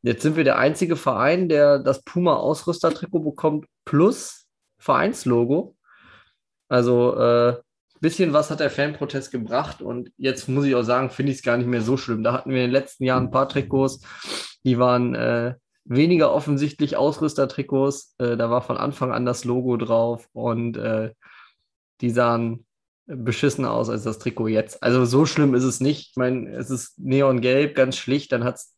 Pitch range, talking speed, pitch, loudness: 120-145 Hz, 175 wpm, 130 Hz, -22 LUFS